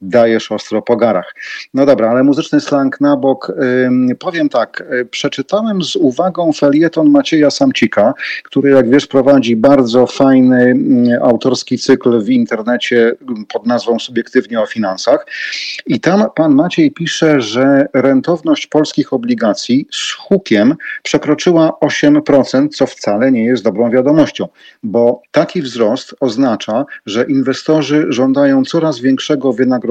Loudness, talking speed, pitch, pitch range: -12 LUFS, 125 wpm, 135 Hz, 125-155 Hz